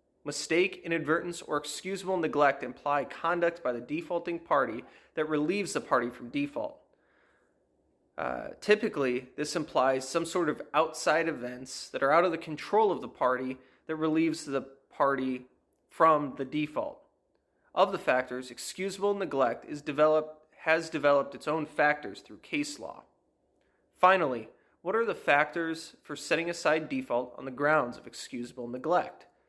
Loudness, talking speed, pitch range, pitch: -30 LUFS, 145 wpm, 135-170 Hz, 155 Hz